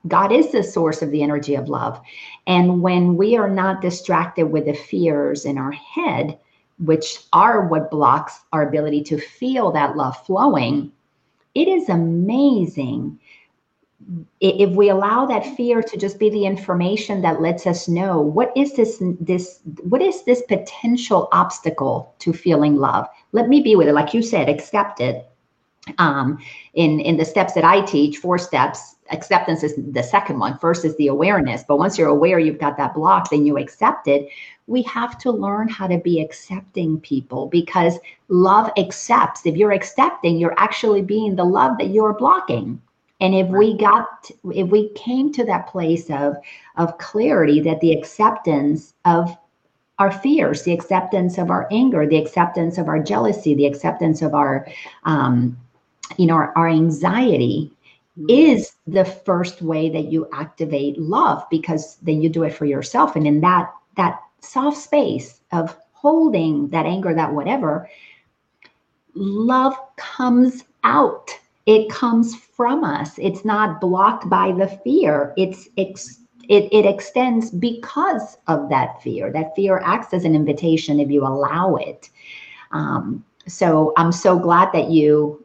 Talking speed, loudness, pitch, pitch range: 160 wpm, -18 LUFS, 175 Hz, 155-210 Hz